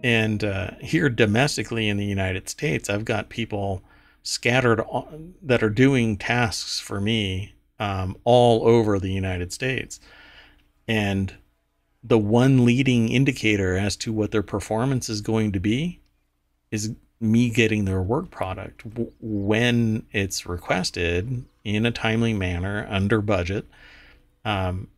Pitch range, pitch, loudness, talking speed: 95-120 Hz, 110 Hz, -23 LUFS, 130 wpm